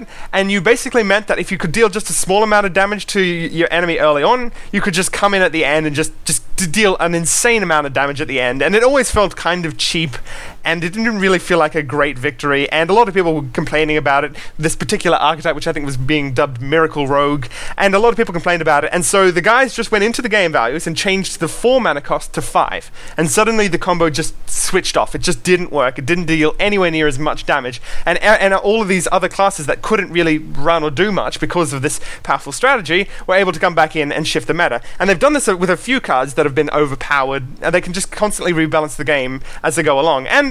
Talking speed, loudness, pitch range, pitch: 265 wpm, -15 LUFS, 150-195 Hz, 170 Hz